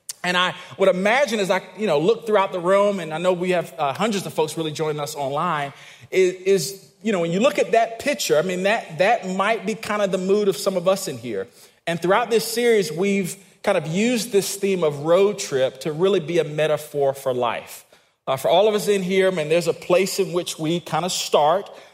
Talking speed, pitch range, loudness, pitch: 245 wpm, 160-200 Hz, -21 LUFS, 185 Hz